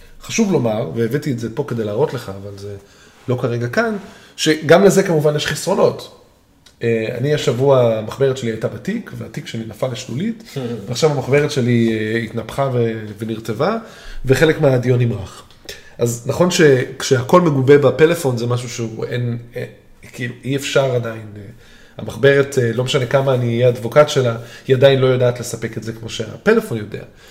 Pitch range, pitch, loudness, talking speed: 115-145 Hz, 125 Hz, -17 LUFS, 150 wpm